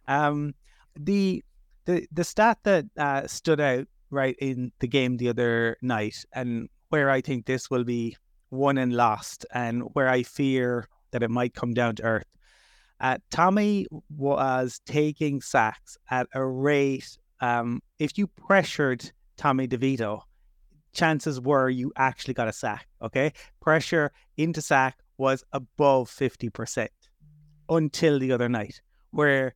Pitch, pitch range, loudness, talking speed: 135 Hz, 125-150 Hz, -26 LUFS, 140 wpm